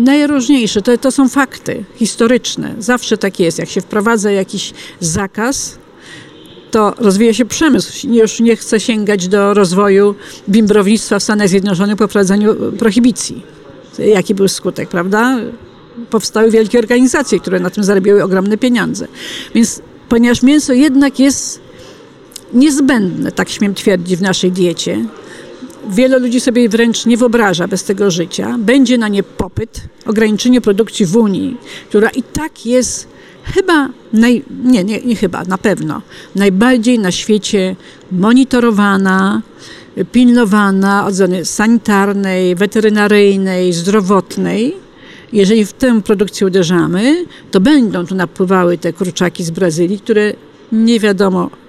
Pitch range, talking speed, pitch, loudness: 195-240 Hz, 130 wpm, 215 Hz, -12 LUFS